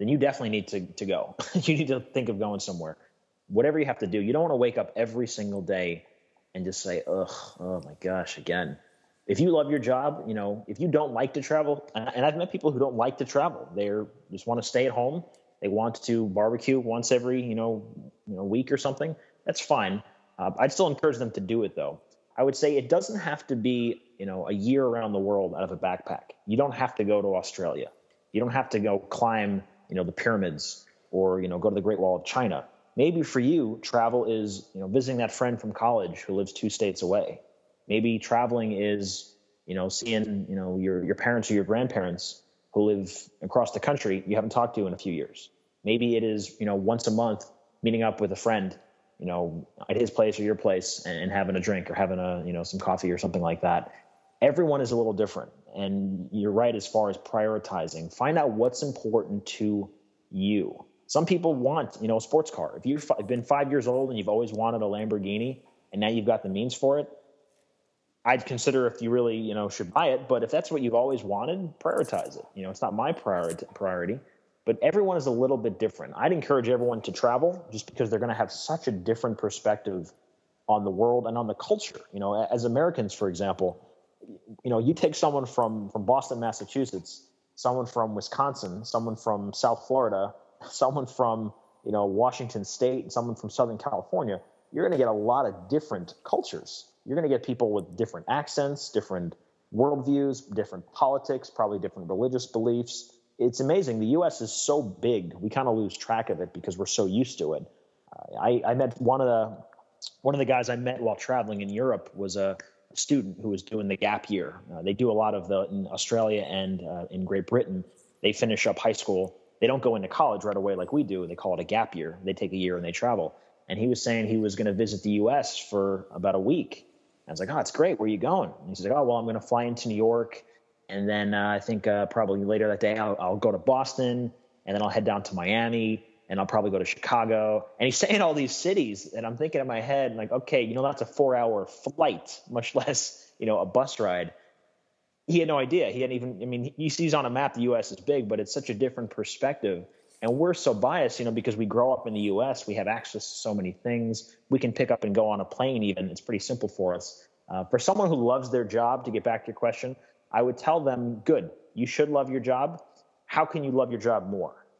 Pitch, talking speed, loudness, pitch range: 115 Hz, 235 wpm, -28 LUFS, 100-125 Hz